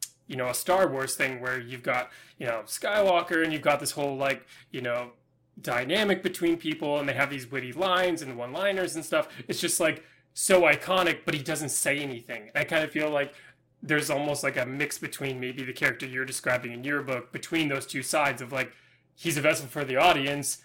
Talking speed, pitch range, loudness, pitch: 220 wpm, 135-160 Hz, -27 LUFS, 145 Hz